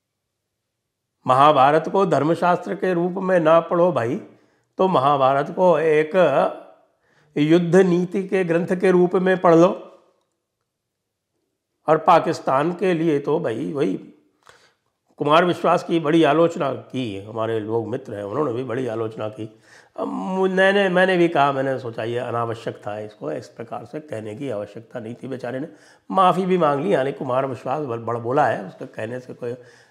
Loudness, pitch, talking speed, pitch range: -20 LUFS, 145 Hz, 155 wpm, 115-175 Hz